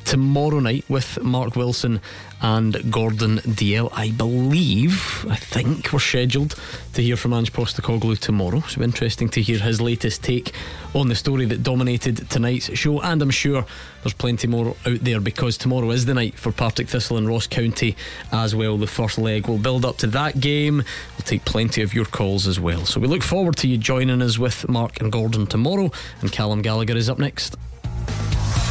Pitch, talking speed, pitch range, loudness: 120 Hz, 190 wpm, 110-130 Hz, -21 LUFS